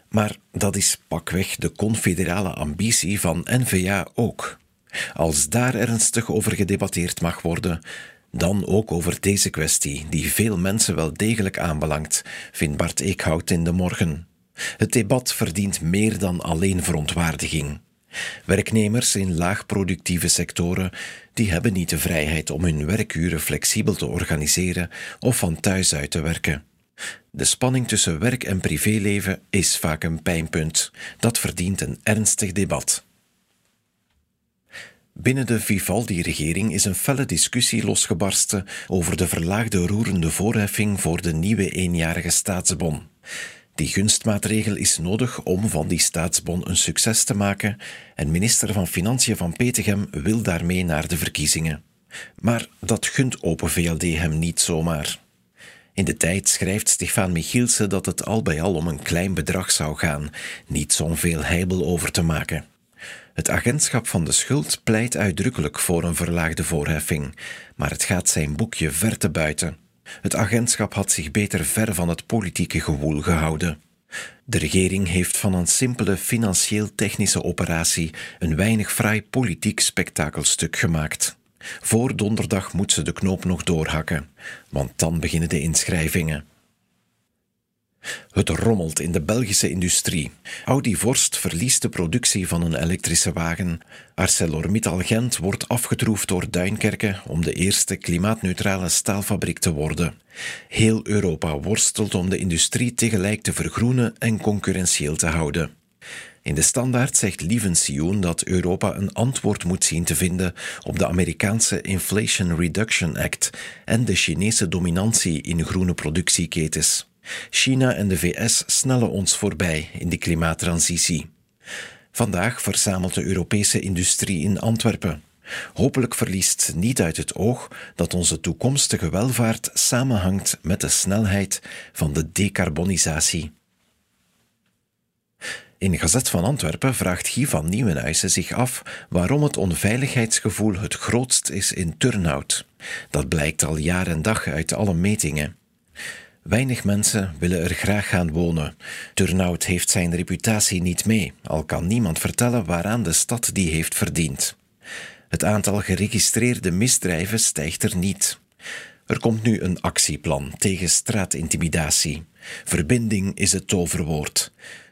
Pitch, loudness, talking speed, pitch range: 95 Hz, -21 LUFS, 135 wpm, 85-105 Hz